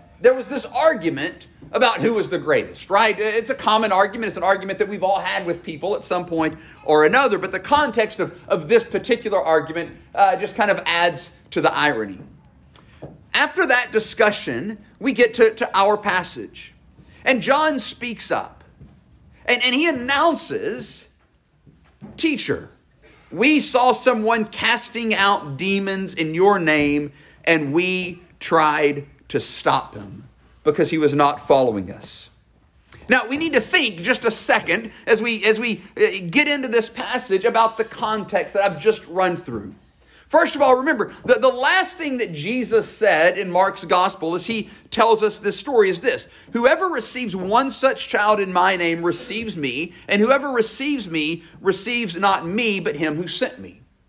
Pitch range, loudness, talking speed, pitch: 175-245 Hz, -19 LUFS, 170 wpm, 210 Hz